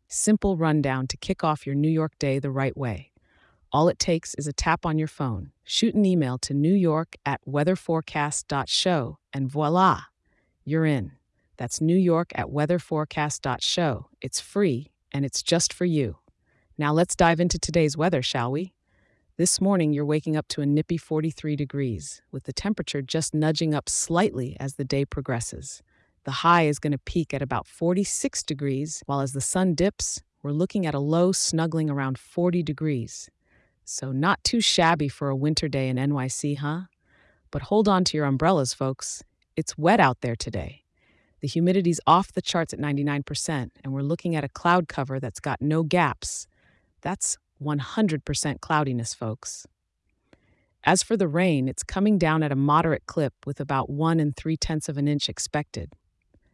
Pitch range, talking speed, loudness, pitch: 135-170 Hz, 170 wpm, -25 LUFS, 150 Hz